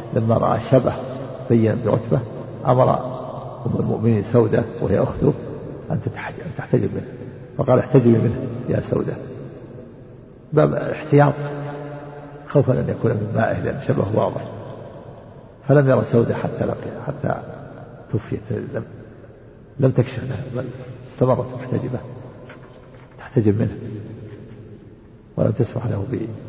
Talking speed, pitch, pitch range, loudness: 110 wpm, 125 Hz, 115-130 Hz, -21 LUFS